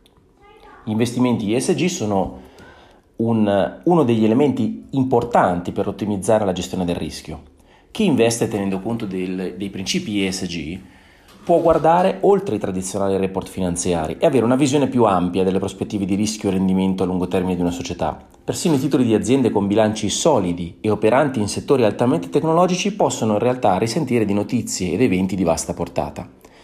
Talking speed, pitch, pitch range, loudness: 160 wpm, 100 Hz, 95-120 Hz, -19 LUFS